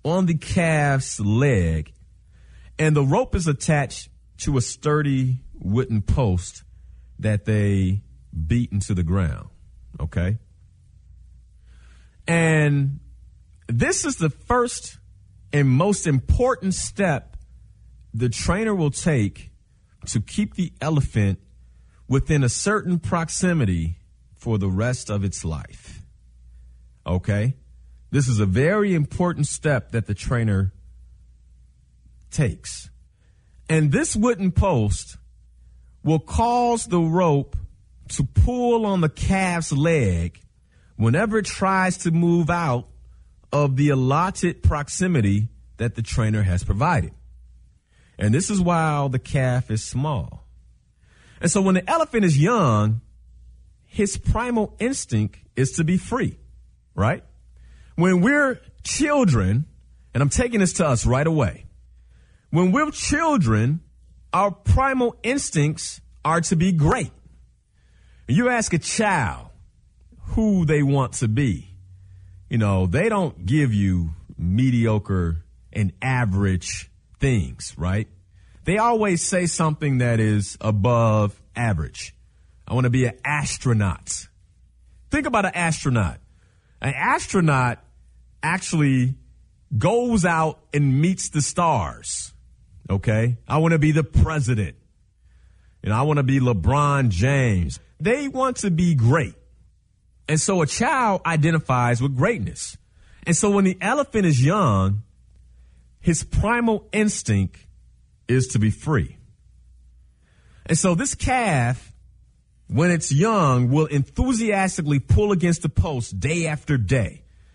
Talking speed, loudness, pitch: 120 wpm, -22 LUFS, 120 Hz